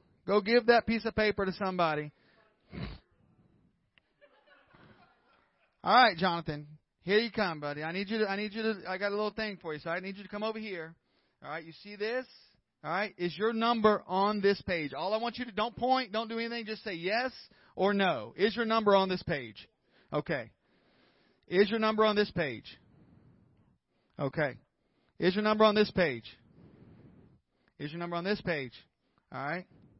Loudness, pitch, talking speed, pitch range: -31 LUFS, 205 Hz, 190 wpm, 170-220 Hz